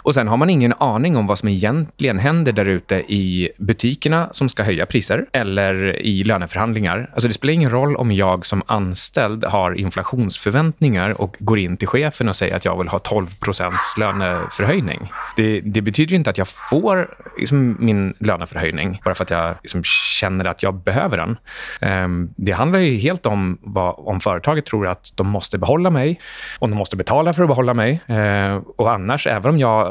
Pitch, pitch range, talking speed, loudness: 105 Hz, 95-130 Hz, 195 wpm, -18 LUFS